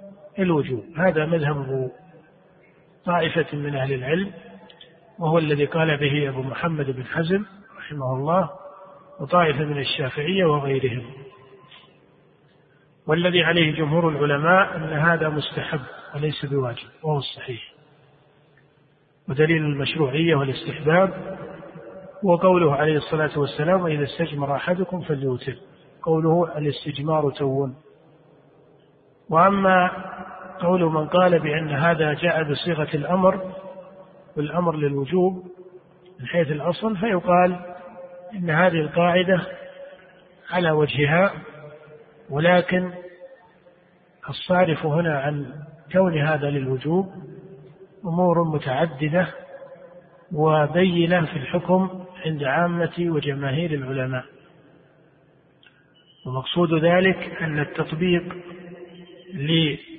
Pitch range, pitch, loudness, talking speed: 150-180 Hz, 165 Hz, -22 LUFS, 85 wpm